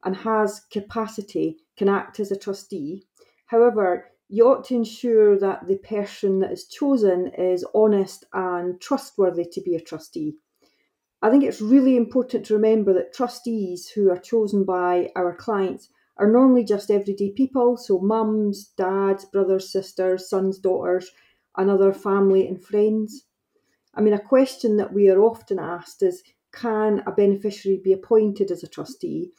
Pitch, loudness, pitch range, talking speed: 205 Hz, -22 LUFS, 190-230 Hz, 155 wpm